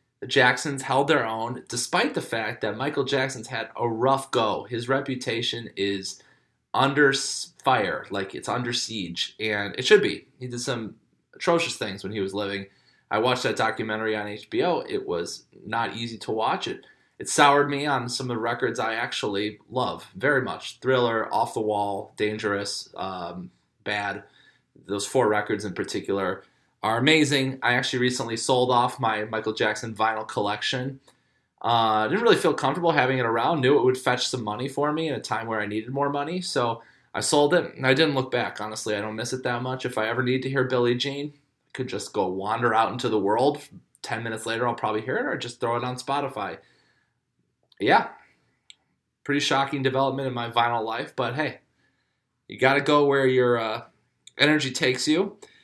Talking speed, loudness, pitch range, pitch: 190 wpm, -25 LUFS, 110-135 Hz, 120 Hz